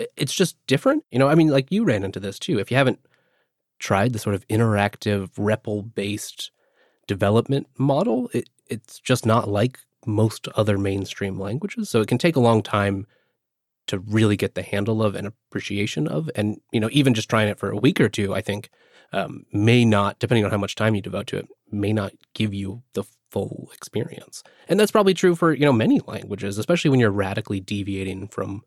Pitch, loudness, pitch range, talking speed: 110 Hz, -22 LUFS, 100-125 Hz, 205 wpm